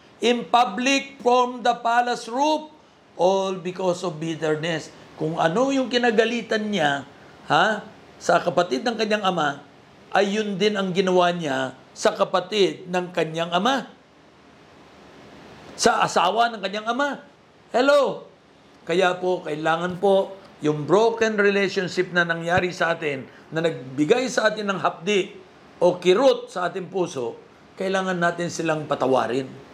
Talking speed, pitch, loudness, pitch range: 130 wpm, 190 Hz, -22 LUFS, 175-235 Hz